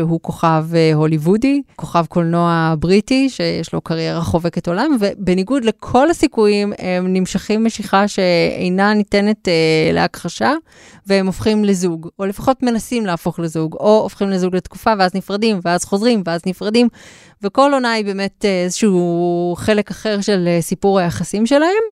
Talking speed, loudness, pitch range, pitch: 140 wpm, -16 LUFS, 175-215 Hz, 195 Hz